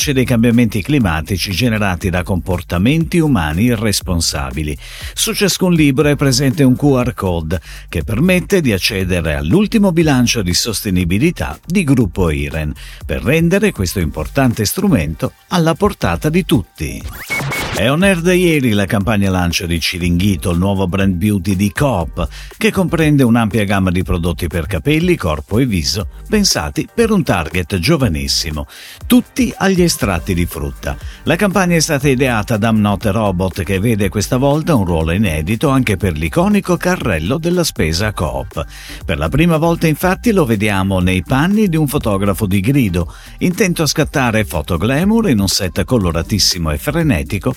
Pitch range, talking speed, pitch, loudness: 90-155 Hz, 150 wpm, 110 Hz, -15 LUFS